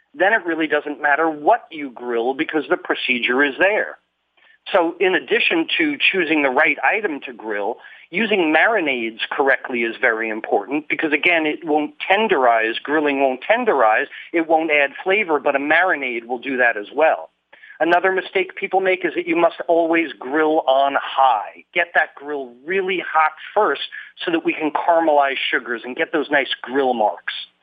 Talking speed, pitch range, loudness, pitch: 170 wpm, 140-180 Hz, -18 LUFS, 155 Hz